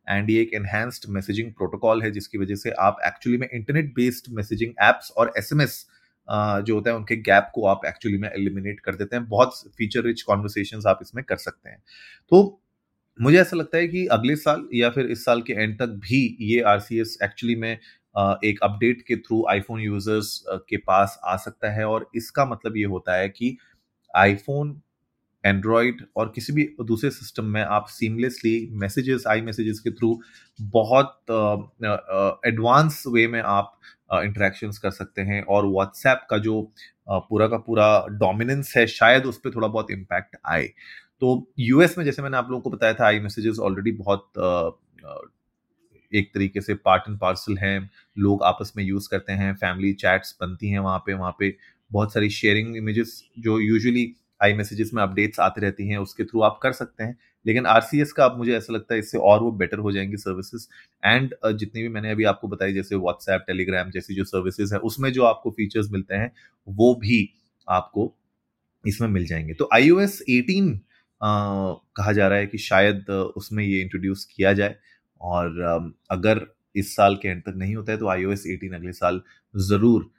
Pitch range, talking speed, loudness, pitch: 100-115 Hz, 190 wpm, -22 LUFS, 110 Hz